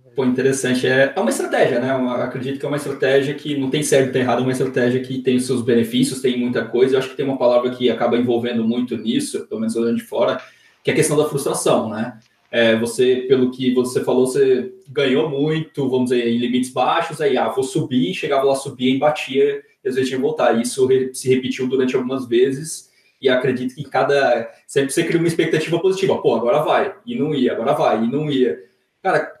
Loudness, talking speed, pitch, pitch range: -19 LUFS, 225 wpm, 130 Hz, 125-145 Hz